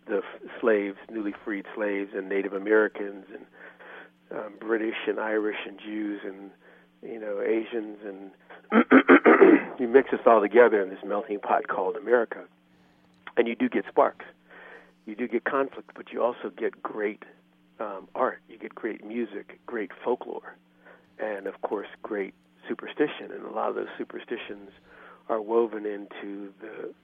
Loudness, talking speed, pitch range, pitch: -26 LUFS, 155 wpm, 95-110 Hz, 105 Hz